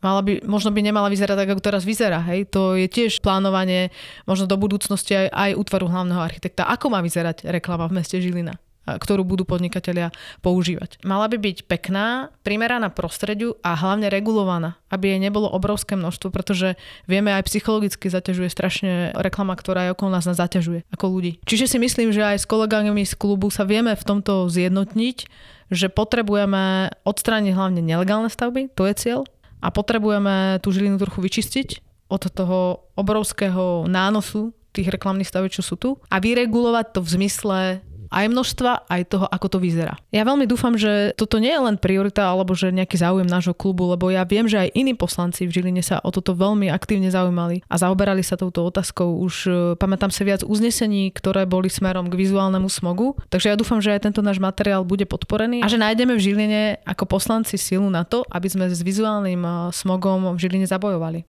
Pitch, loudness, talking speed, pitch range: 195 Hz, -21 LUFS, 185 wpm, 185-210 Hz